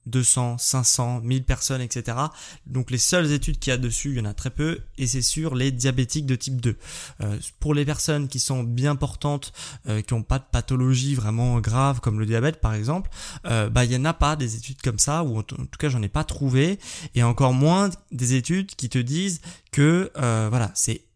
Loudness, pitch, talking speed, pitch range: -23 LUFS, 130 Hz, 225 wpm, 120-145 Hz